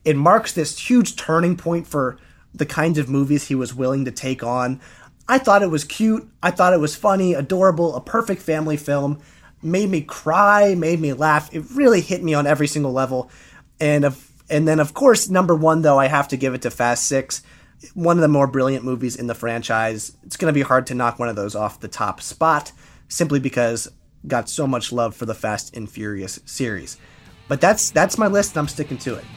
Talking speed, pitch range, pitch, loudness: 220 wpm, 125-170 Hz, 145 Hz, -19 LUFS